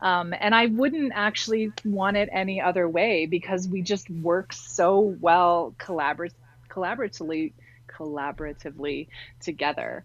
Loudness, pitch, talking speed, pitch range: -25 LUFS, 175 Hz, 120 wpm, 150-195 Hz